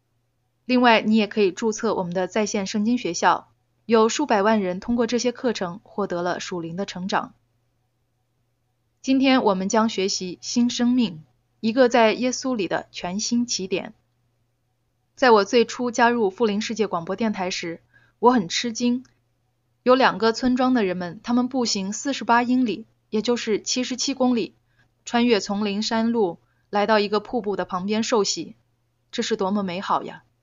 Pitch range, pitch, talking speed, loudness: 170-235 Hz, 205 Hz, 245 characters per minute, -22 LUFS